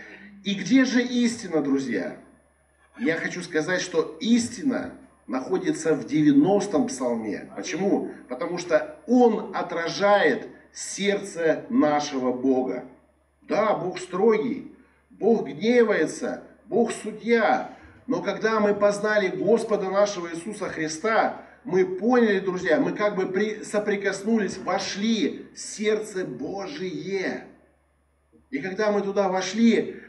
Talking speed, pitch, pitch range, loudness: 105 wpm, 200 Hz, 170-225 Hz, -24 LUFS